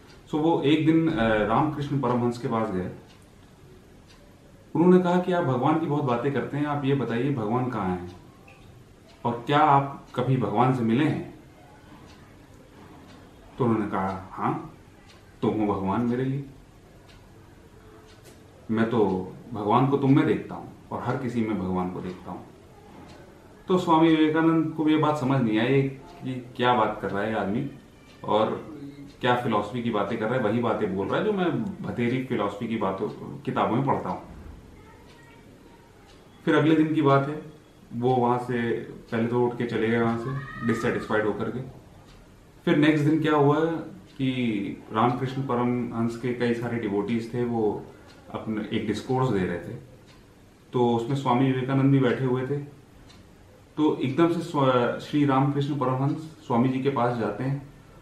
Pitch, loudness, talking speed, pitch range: 120 Hz, -25 LUFS, 165 wpm, 105-140 Hz